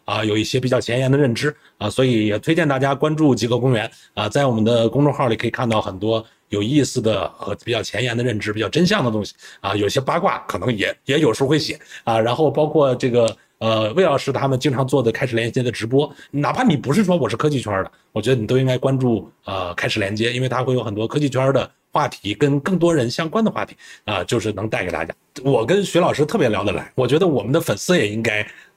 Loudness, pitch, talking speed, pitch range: -19 LUFS, 130 Hz, 365 characters per minute, 110-145 Hz